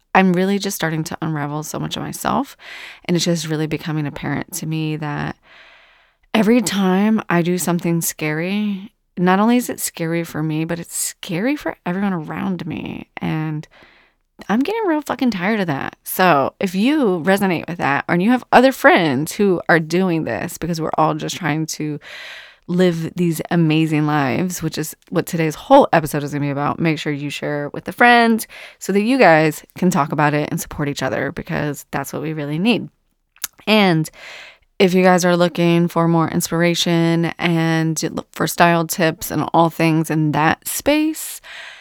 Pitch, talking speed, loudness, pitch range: 170 Hz, 185 wpm, -18 LUFS, 155-195 Hz